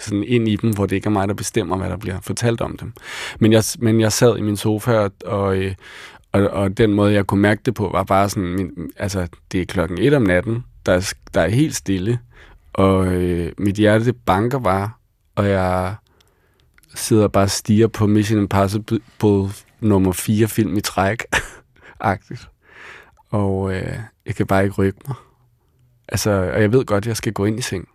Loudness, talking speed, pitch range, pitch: -19 LUFS, 200 wpm, 95-110 Hz, 105 Hz